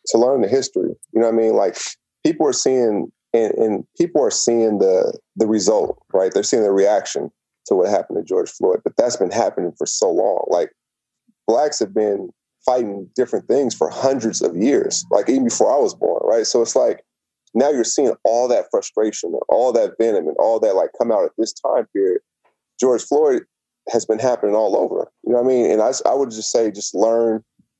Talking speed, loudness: 215 wpm, -18 LUFS